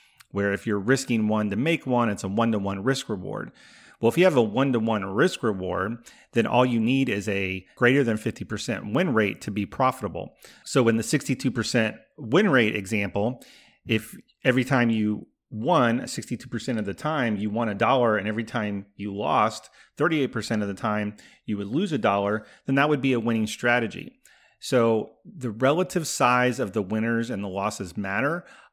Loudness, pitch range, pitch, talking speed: -25 LUFS, 105-125 Hz, 115 Hz, 190 wpm